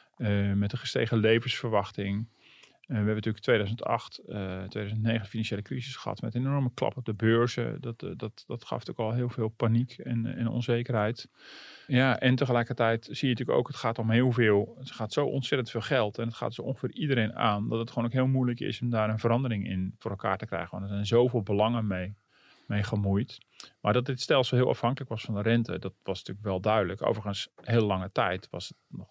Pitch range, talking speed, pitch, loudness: 105-125 Hz, 225 wpm, 115 Hz, -29 LUFS